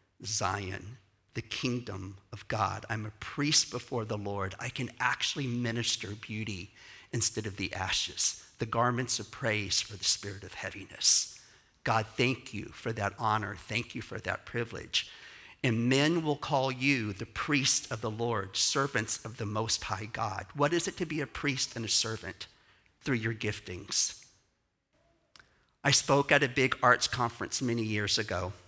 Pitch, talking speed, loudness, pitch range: 115 Hz, 165 wpm, -31 LUFS, 105-125 Hz